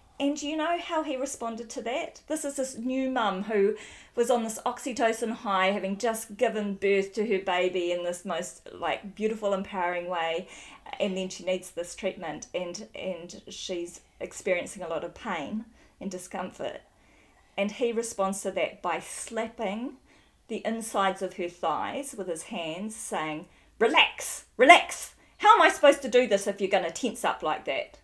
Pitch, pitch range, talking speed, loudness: 210 Hz, 190-250 Hz, 175 wpm, -28 LUFS